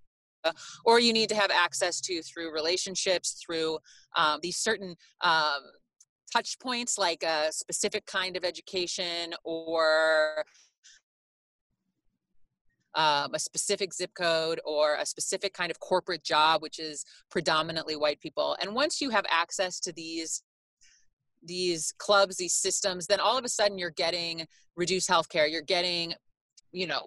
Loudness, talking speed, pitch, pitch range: -28 LUFS, 145 wpm, 175 Hz, 160-190 Hz